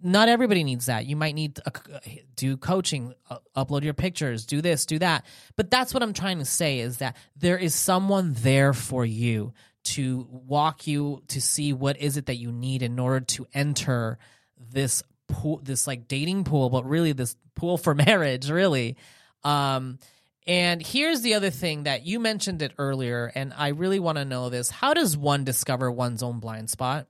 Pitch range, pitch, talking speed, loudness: 130-165 Hz, 140 Hz, 190 wpm, -25 LUFS